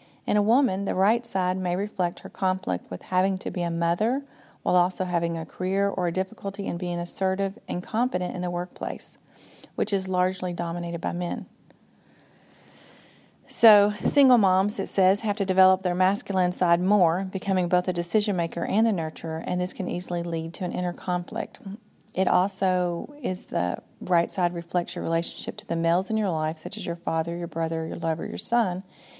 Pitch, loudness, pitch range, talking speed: 185 Hz, -26 LUFS, 175-200 Hz, 190 wpm